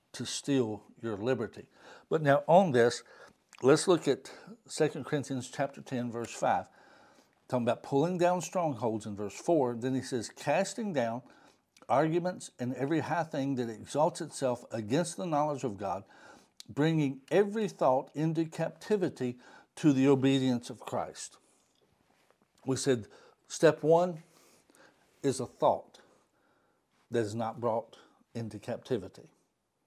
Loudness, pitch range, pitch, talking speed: -31 LUFS, 120-160 Hz, 135 Hz, 135 wpm